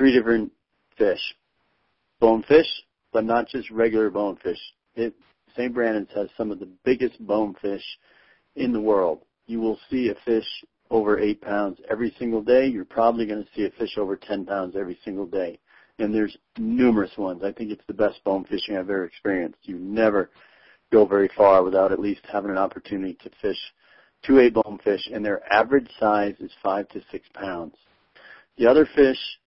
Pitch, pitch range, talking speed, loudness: 110 Hz, 100-120 Hz, 185 wpm, -23 LUFS